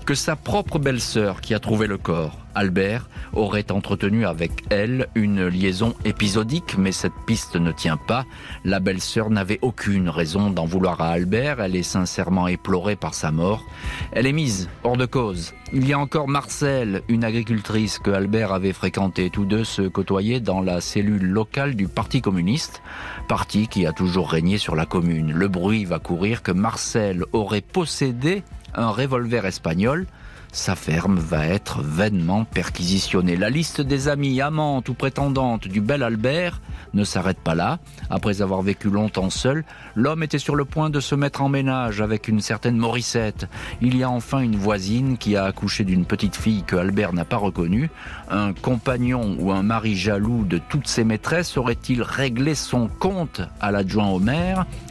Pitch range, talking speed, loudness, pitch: 95-125 Hz, 175 wpm, -22 LUFS, 105 Hz